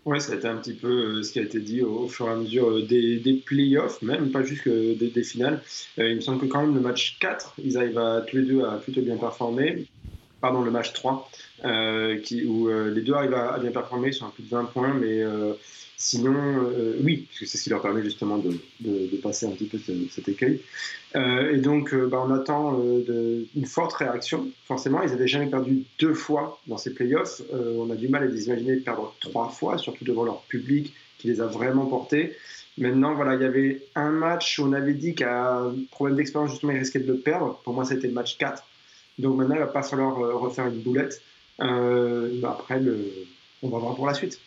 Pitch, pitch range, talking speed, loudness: 125 Hz, 115-140 Hz, 245 wpm, -25 LUFS